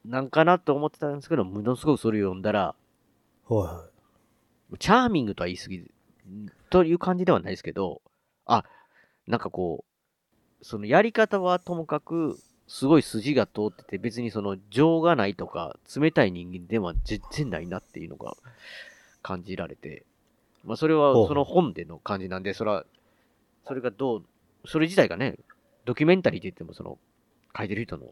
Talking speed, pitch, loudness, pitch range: 325 characters per minute, 125 Hz, -26 LUFS, 100-160 Hz